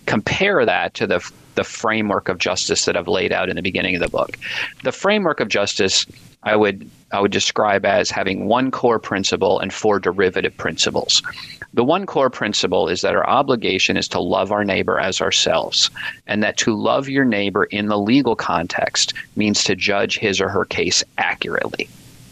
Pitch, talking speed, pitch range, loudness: 105 Hz, 185 wpm, 100-105 Hz, -18 LUFS